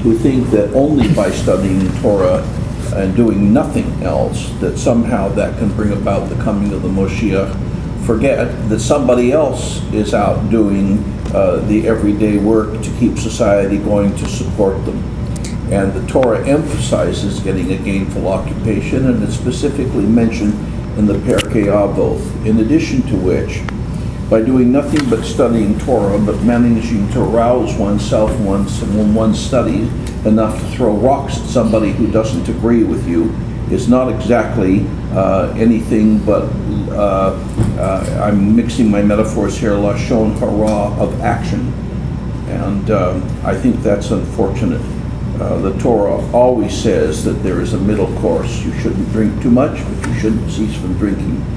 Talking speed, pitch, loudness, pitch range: 155 wpm, 110 Hz, -15 LUFS, 100-115 Hz